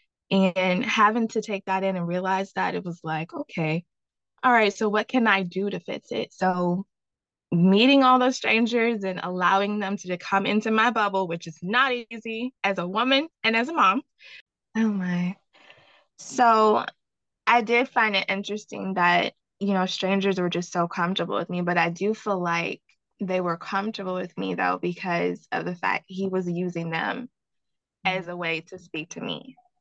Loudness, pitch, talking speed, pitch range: -24 LUFS, 195 Hz, 185 wpm, 180-225 Hz